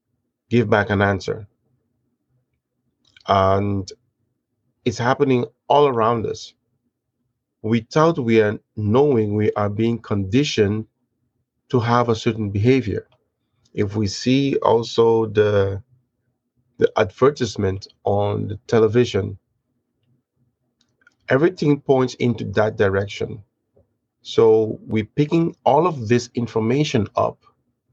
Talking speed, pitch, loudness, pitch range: 100 wpm, 120 Hz, -20 LUFS, 110-125 Hz